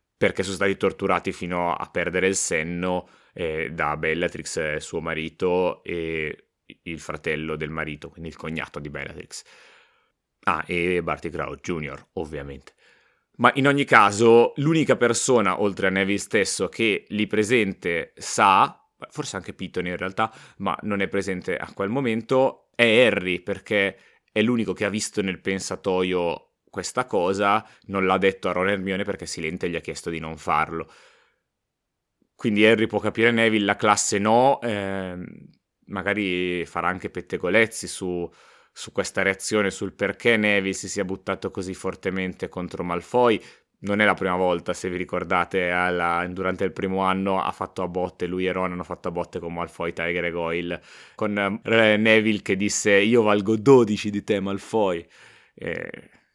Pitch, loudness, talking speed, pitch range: 95 Hz, -23 LUFS, 160 wpm, 90-105 Hz